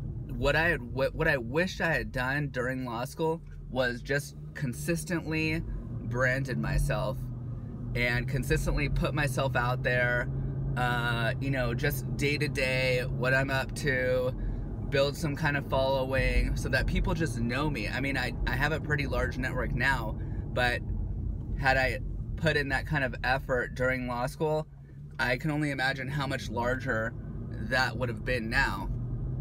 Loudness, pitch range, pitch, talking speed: -30 LUFS, 120-140 Hz, 130 Hz, 155 wpm